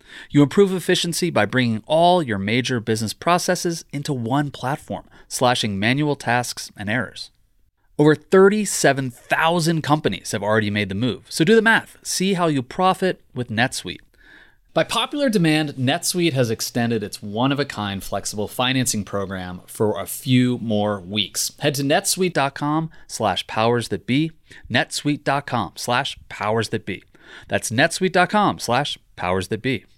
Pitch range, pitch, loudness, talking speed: 110-165 Hz, 130 Hz, -21 LUFS, 140 wpm